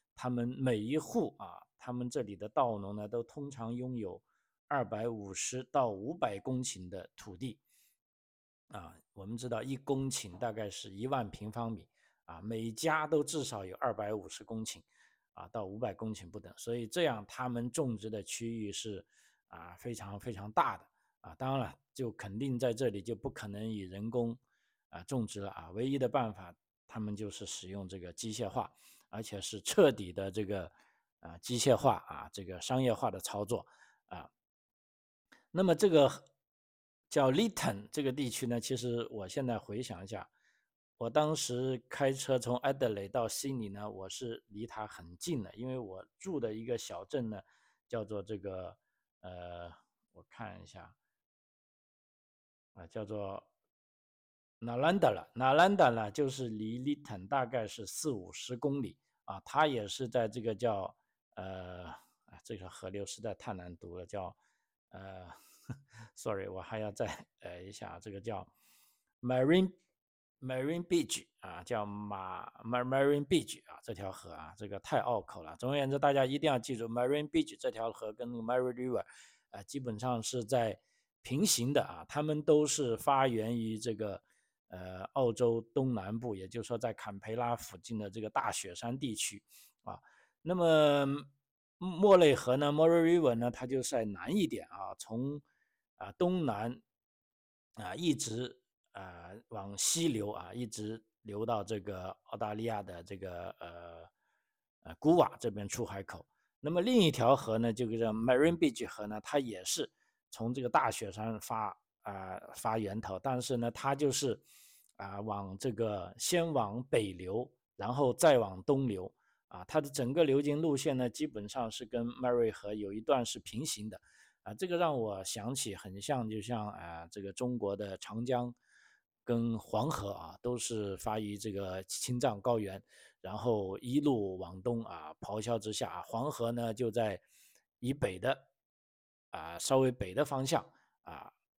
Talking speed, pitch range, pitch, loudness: 250 characters per minute, 100-130 Hz, 115 Hz, -35 LUFS